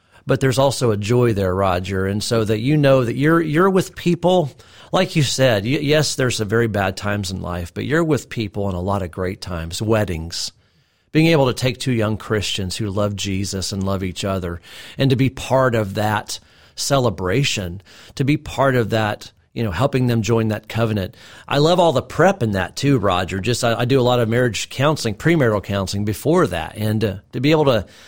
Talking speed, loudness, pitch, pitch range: 215 wpm, -19 LUFS, 115 Hz, 100-135 Hz